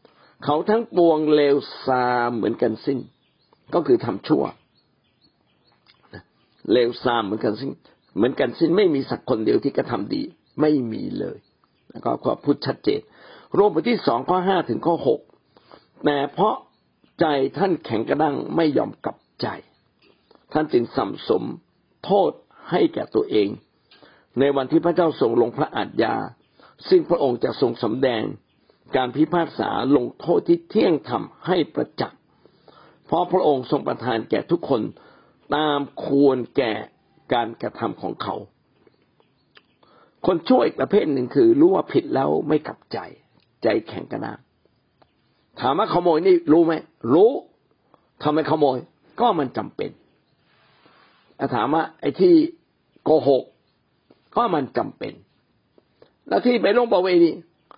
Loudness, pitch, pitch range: -21 LUFS, 155 Hz, 130-185 Hz